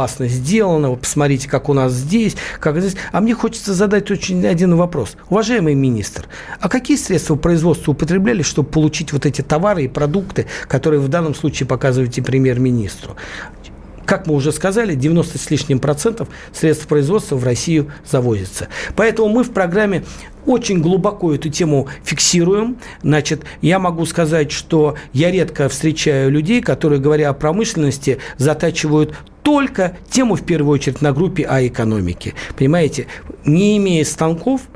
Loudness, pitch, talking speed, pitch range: -16 LUFS, 155 Hz, 145 wpm, 140-185 Hz